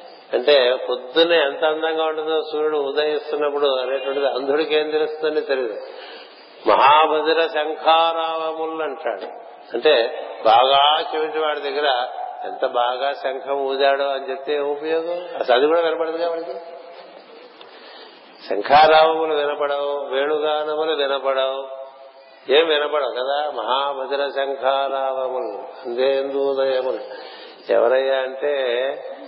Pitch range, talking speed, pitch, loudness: 135-155 Hz, 90 wpm, 145 Hz, -20 LUFS